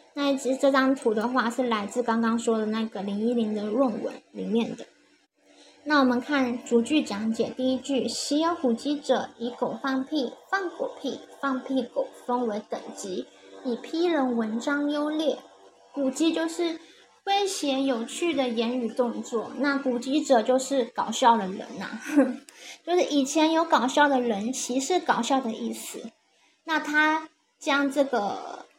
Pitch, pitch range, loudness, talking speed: 260 Hz, 235-295 Hz, -26 LUFS, 225 characters per minute